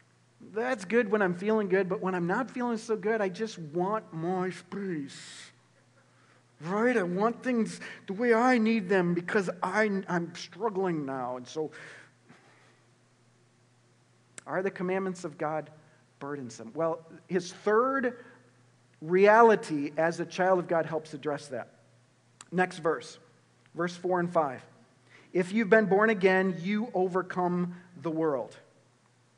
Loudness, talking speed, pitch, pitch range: -29 LUFS, 135 wpm, 180 Hz, 150-205 Hz